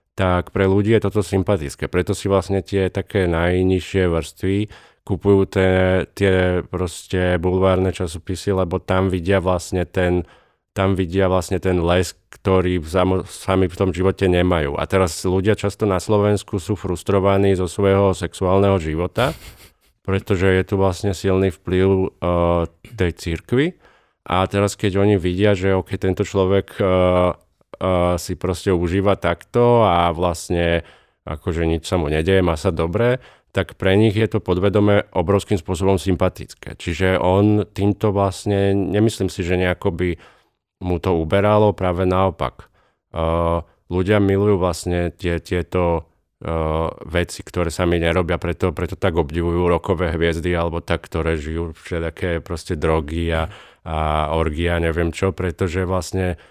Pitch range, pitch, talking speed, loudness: 85-100 Hz, 95 Hz, 145 wpm, -19 LUFS